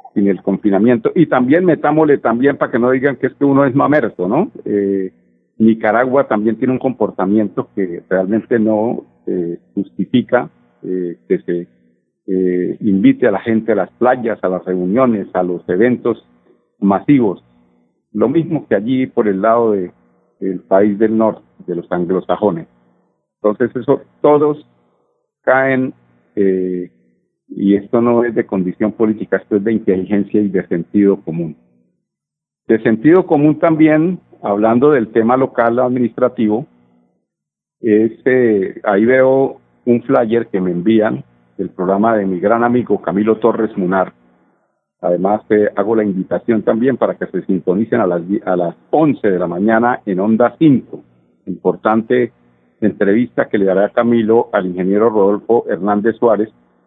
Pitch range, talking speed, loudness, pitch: 90-120 Hz, 150 wpm, -15 LUFS, 105 Hz